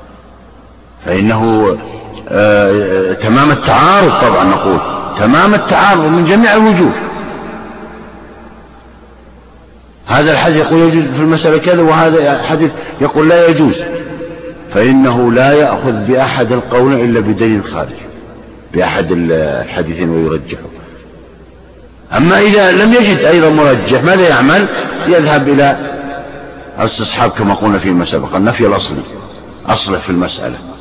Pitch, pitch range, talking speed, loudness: 130 Hz, 95-160 Hz, 110 wpm, -10 LUFS